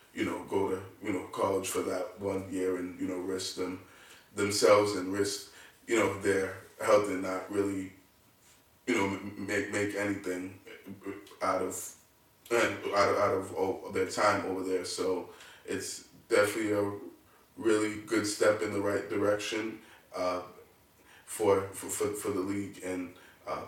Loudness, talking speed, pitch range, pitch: -31 LUFS, 155 wpm, 95-100 Hz, 100 Hz